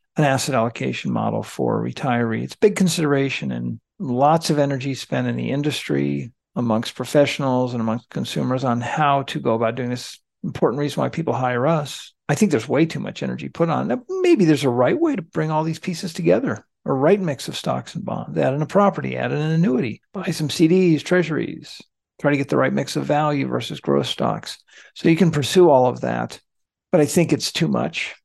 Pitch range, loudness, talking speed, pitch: 120-165 Hz, -21 LUFS, 210 wpm, 145 Hz